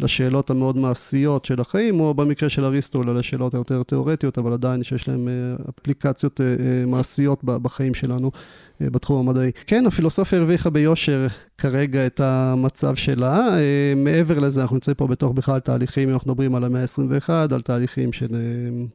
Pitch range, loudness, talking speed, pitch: 125-145 Hz, -21 LUFS, 150 wpm, 135 Hz